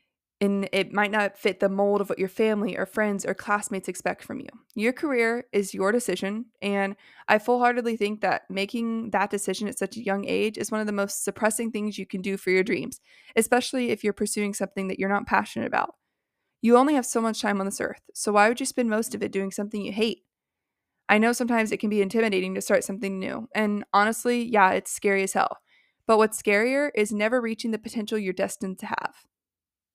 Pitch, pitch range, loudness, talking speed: 210 Hz, 200-230 Hz, -25 LUFS, 220 wpm